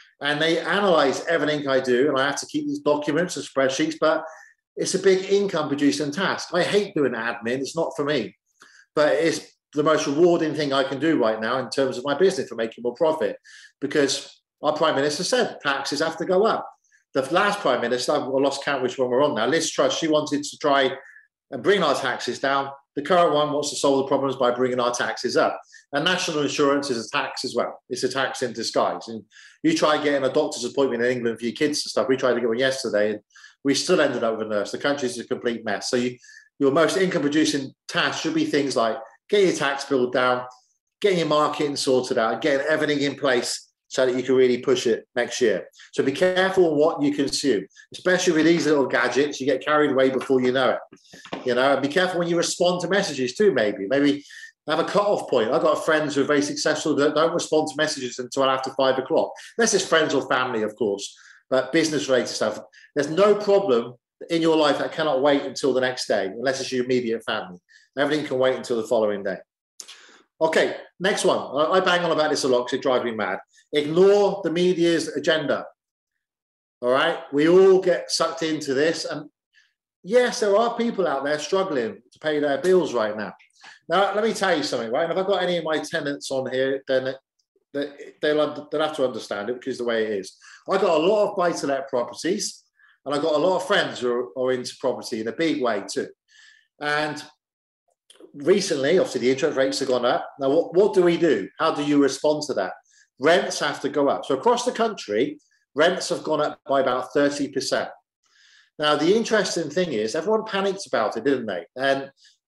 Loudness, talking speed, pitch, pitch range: -22 LUFS, 215 wpm, 150 Hz, 130-175 Hz